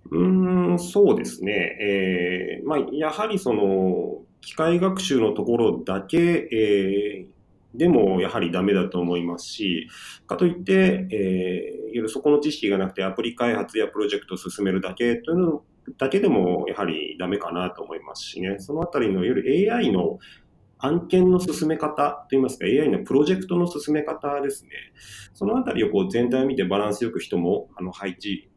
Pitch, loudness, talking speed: 140 Hz, -23 LUFS, 345 characters per minute